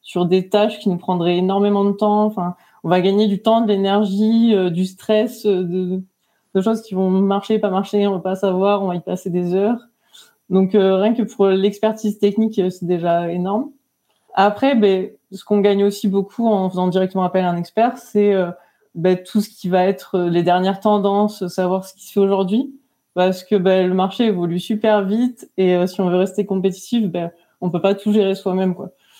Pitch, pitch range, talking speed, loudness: 195 Hz, 185-210 Hz, 210 wpm, -18 LUFS